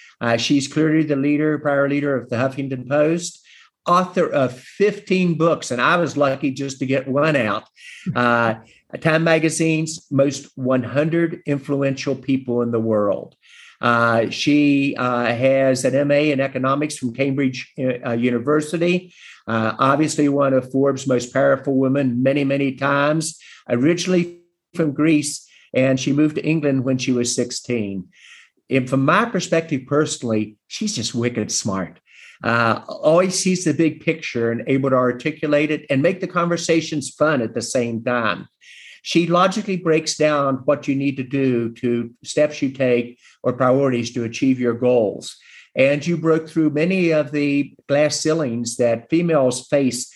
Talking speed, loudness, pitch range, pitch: 155 wpm, -19 LUFS, 125-155 Hz, 140 Hz